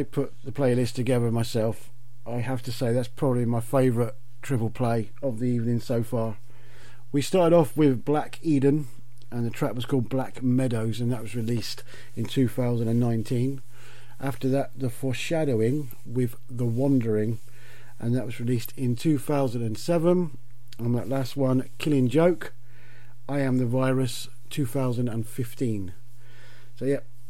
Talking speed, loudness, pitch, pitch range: 145 wpm, -26 LUFS, 125 Hz, 120-135 Hz